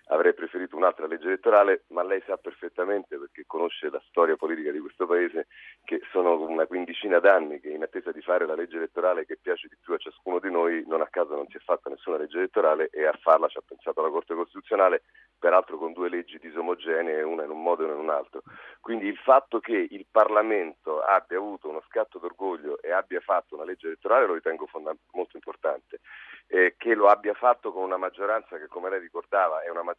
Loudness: -26 LUFS